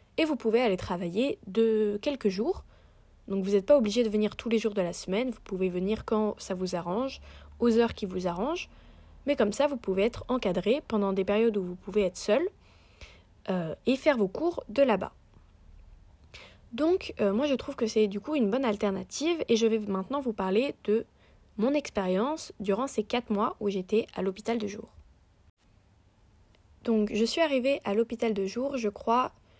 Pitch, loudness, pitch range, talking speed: 215 Hz, -29 LUFS, 190-245 Hz, 195 wpm